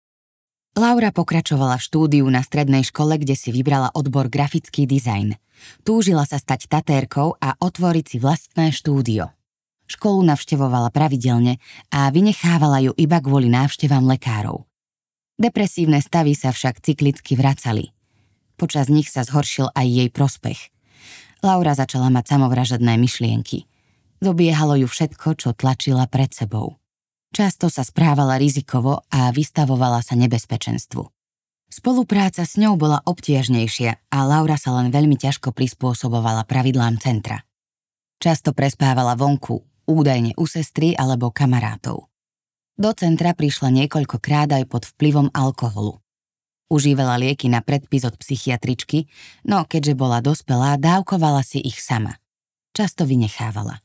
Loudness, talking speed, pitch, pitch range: -19 LUFS, 125 wpm, 135 Hz, 125-155 Hz